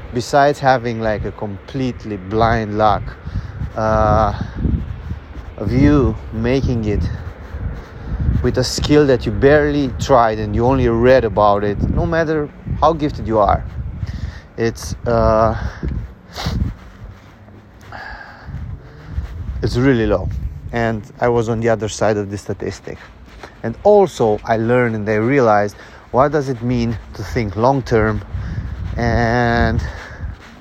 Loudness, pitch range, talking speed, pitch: -17 LUFS, 100-125 Hz, 120 wpm, 110 Hz